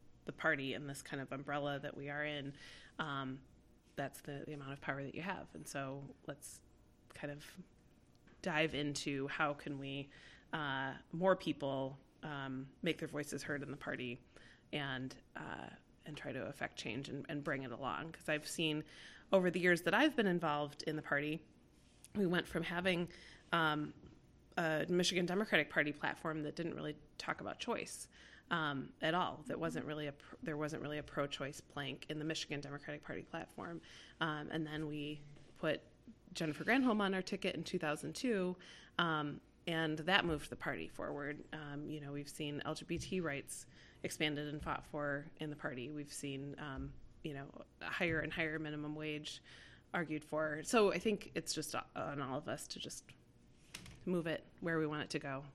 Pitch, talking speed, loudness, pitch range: 150 Hz, 180 wpm, -40 LUFS, 145-160 Hz